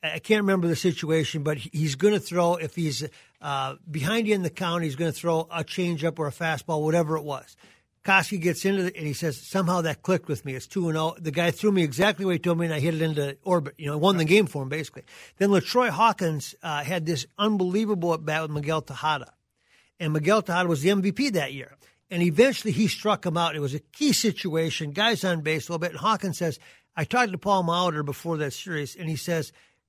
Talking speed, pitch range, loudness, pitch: 245 wpm, 155-190 Hz, -25 LUFS, 170 Hz